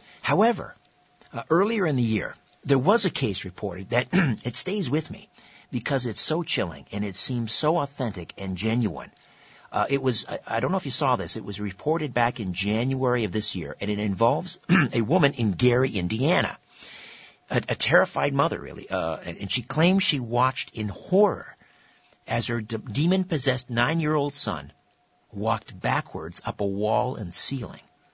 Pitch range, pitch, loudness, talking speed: 105-150 Hz, 120 Hz, -25 LUFS, 180 wpm